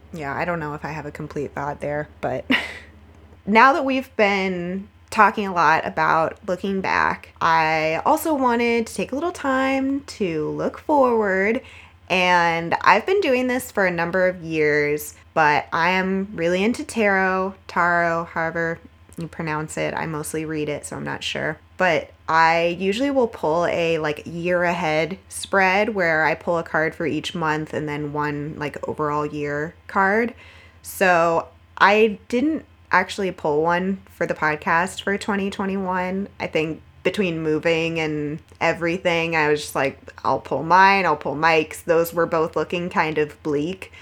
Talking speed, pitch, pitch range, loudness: 165 wpm, 170 Hz, 155-195 Hz, -21 LUFS